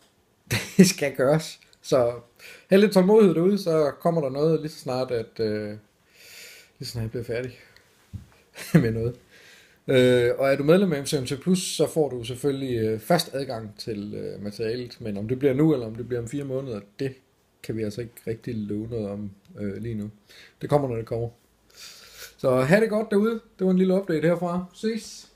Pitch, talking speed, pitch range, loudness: 130 Hz, 200 wpm, 115-165 Hz, -24 LUFS